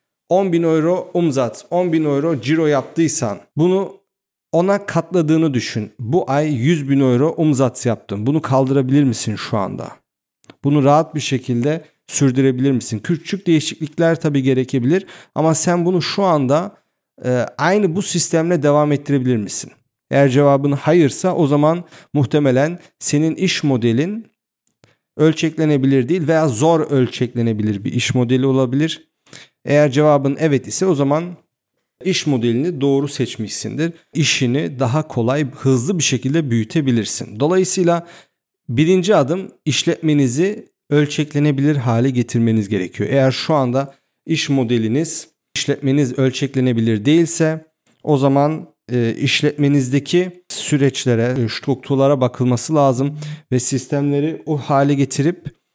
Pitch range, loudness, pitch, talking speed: 130-160 Hz, -17 LUFS, 145 Hz, 115 wpm